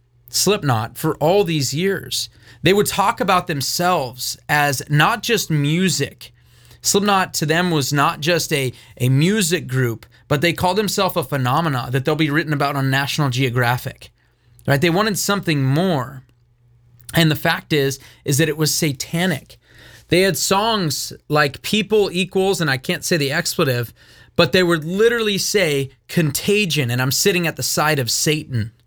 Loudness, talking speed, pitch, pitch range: -18 LUFS, 160 wpm, 150 Hz, 130-180 Hz